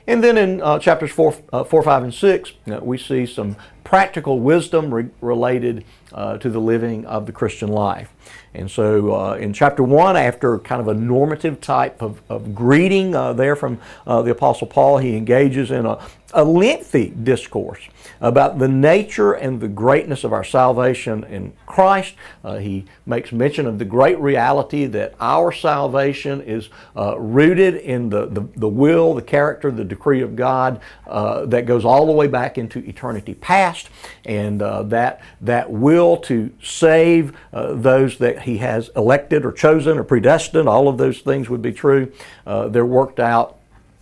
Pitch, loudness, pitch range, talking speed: 125 Hz, -17 LUFS, 115-145 Hz, 175 wpm